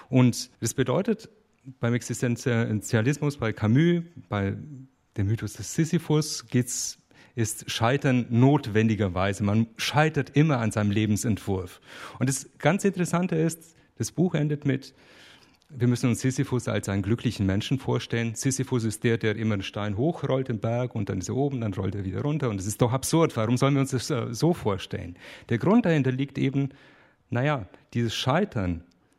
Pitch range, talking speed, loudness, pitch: 110-140 Hz, 165 wpm, -26 LUFS, 125 Hz